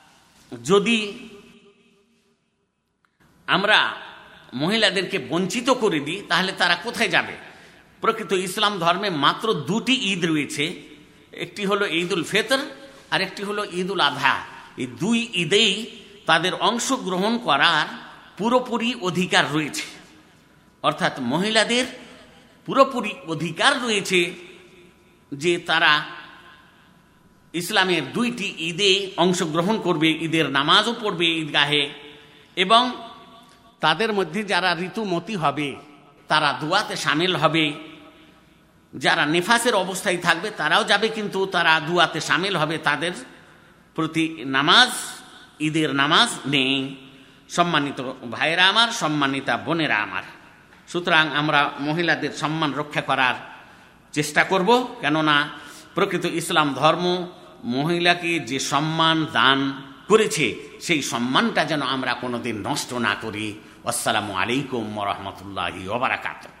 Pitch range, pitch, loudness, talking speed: 145-205 Hz, 170 Hz, -21 LUFS, 100 wpm